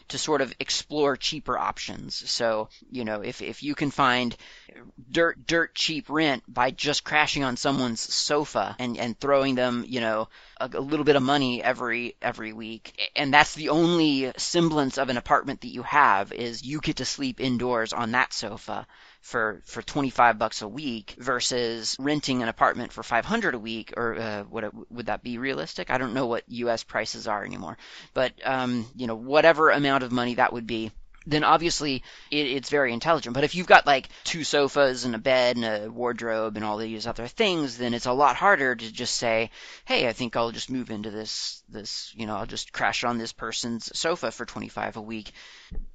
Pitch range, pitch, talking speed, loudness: 115-145 Hz, 125 Hz, 210 wpm, -25 LUFS